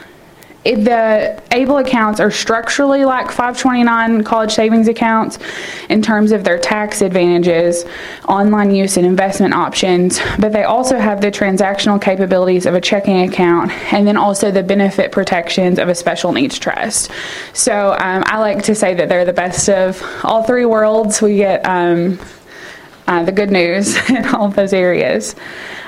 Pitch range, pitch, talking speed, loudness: 185-225 Hz, 205 Hz, 160 wpm, -13 LUFS